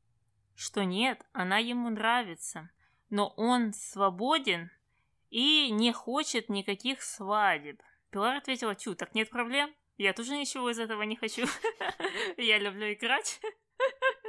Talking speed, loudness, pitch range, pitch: 120 wpm, -30 LUFS, 200-265 Hz, 230 Hz